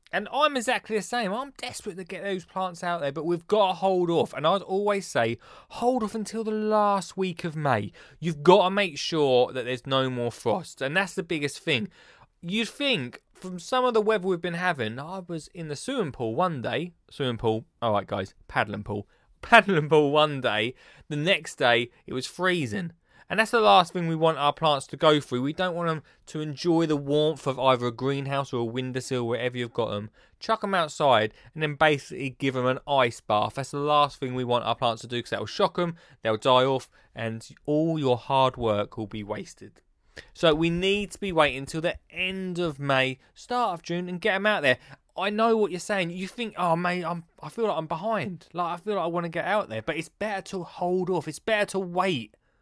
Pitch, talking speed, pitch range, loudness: 165 Hz, 230 wpm, 130-190 Hz, -26 LUFS